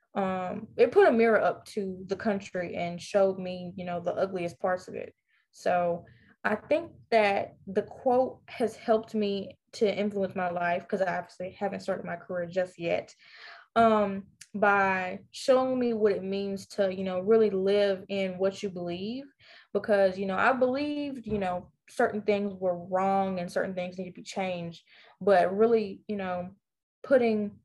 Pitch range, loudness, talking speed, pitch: 185-220 Hz, -28 LUFS, 175 wpm, 195 Hz